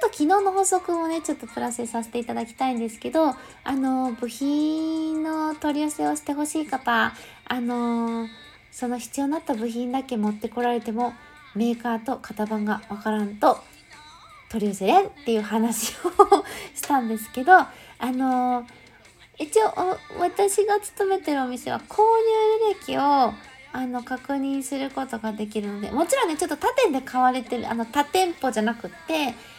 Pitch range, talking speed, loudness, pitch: 235-325 Hz, 330 characters per minute, -24 LUFS, 265 Hz